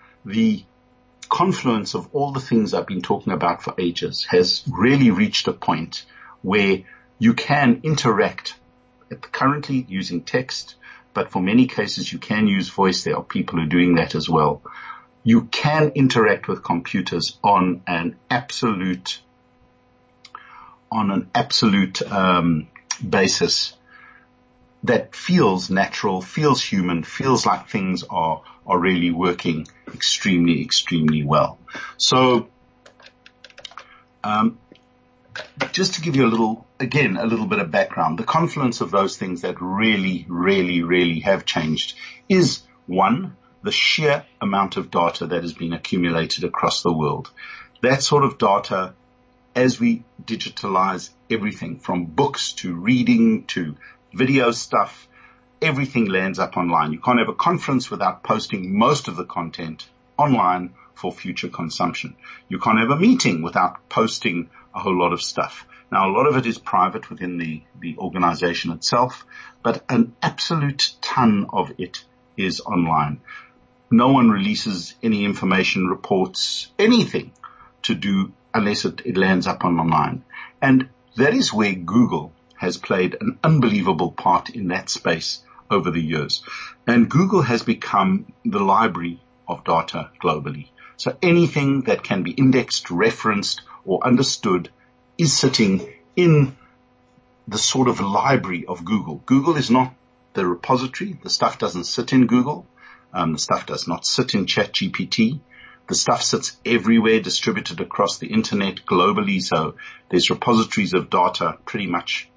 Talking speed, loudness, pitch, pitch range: 145 wpm, -20 LUFS, 115 Hz, 90-140 Hz